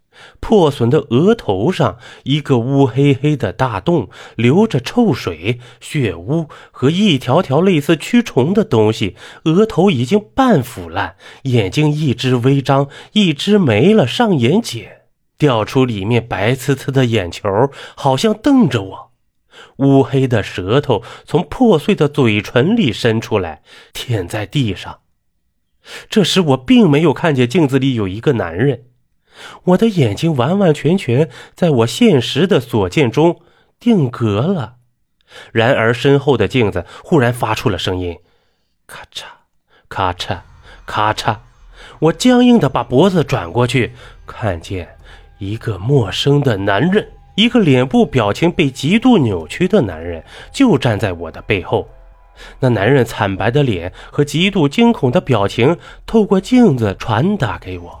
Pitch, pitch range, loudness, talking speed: 135 Hz, 110-170 Hz, -15 LUFS, 210 characters per minute